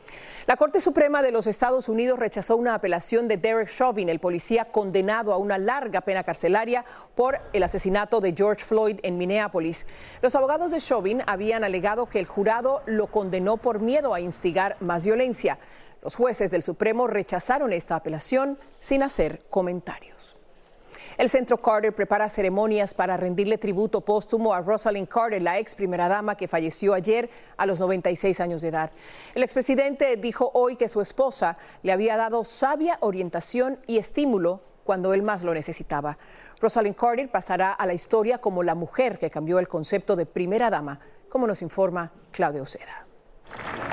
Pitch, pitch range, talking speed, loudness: 210 Hz, 185-235 Hz, 165 wpm, -24 LUFS